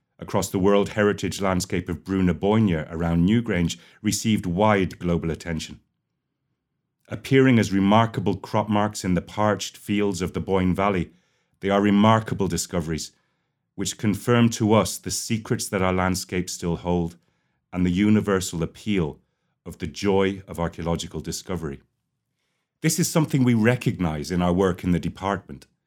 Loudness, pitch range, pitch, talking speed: -23 LUFS, 85-105 Hz, 95 Hz, 145 wpm